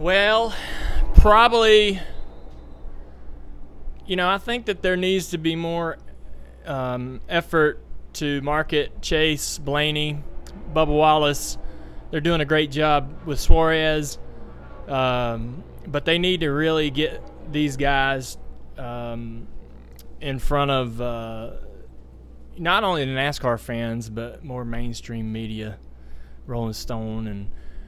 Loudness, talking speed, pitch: -22 LUFS, 115 wpm, 130 Hz